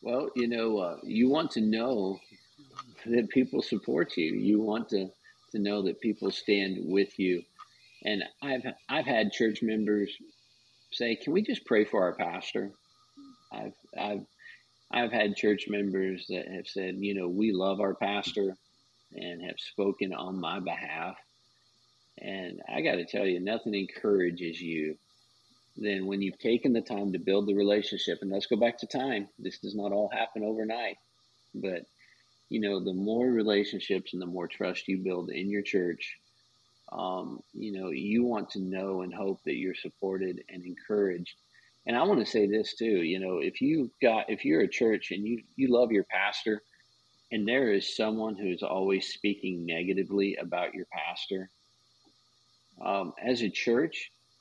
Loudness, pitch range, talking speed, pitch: -31 LUFS, 95-110 Hz, 170 wpm, 100 Hz